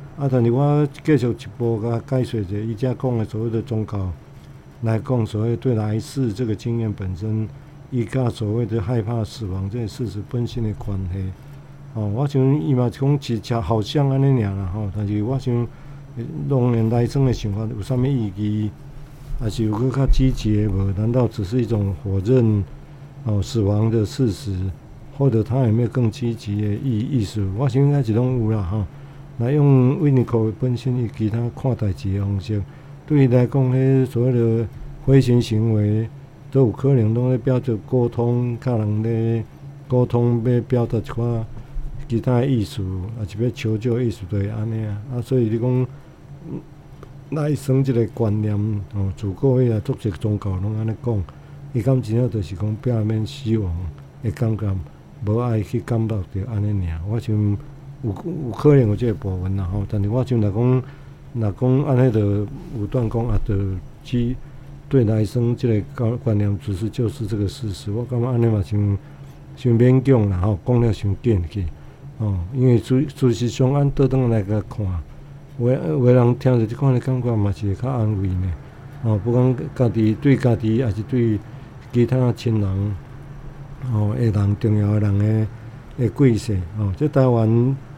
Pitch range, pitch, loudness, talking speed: 105-130 Hz, 120 Hz, -21 LUFS, 250 characters per minute